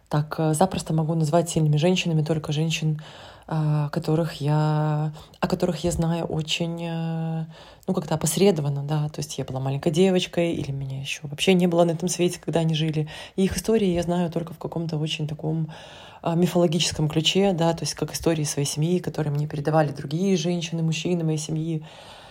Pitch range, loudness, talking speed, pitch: 155-175 Hz, -24 LUFS, 170 wpm, 160 Hz